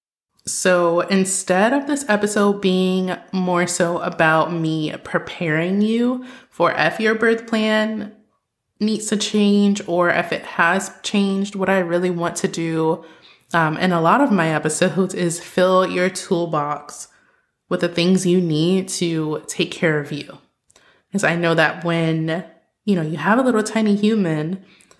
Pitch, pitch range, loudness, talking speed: 185 Hz, 170-205 Hz, -19 LUFS, 155 wpm